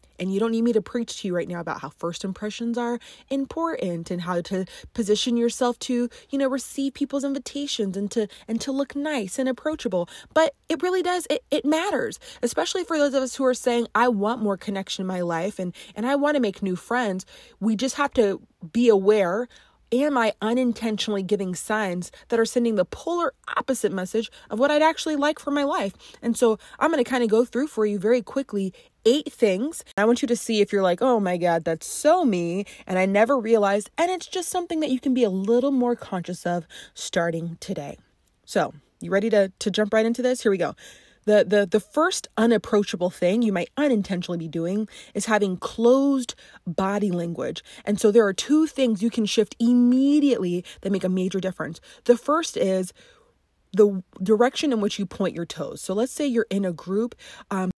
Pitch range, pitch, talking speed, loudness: 195-265 Hz, 225 Hz, 210 wpm, -24 LUFS